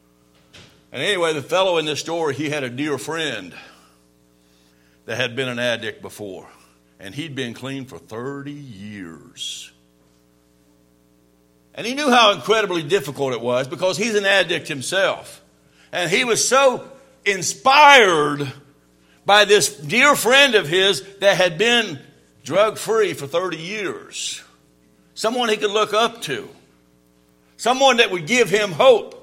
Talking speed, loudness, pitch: 140 wpm, -18 LUFS, 150 Hz